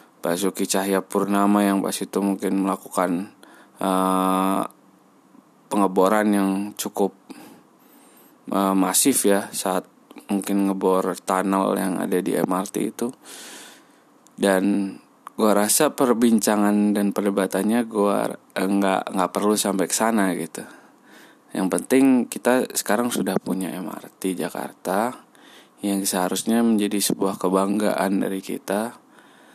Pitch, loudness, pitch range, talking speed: 100 Hz, -22 LUFS, 95-105 Hz, 110 wpm